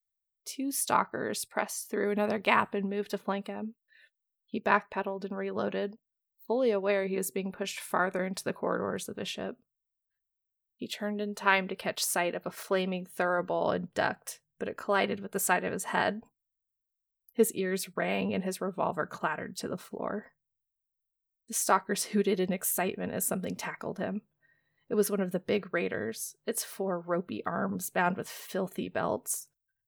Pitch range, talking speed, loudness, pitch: 185-210 Hz, 170 wpm, -32 LUFS, 195 Hz